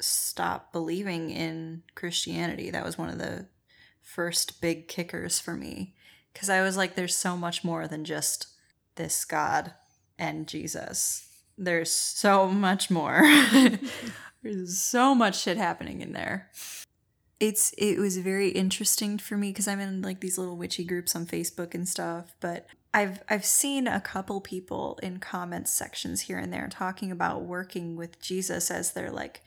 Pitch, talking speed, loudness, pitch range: 185 Hz, 160 wpm, -27 LUFS, 170-200 Hz